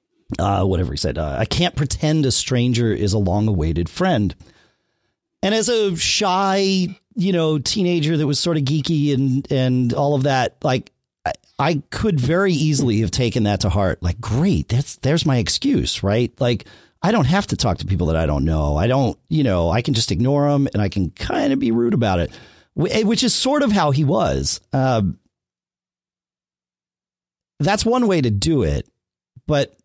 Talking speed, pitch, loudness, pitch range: 190 wpm, 130 Hz, -19 LUFS, 100-160 Hz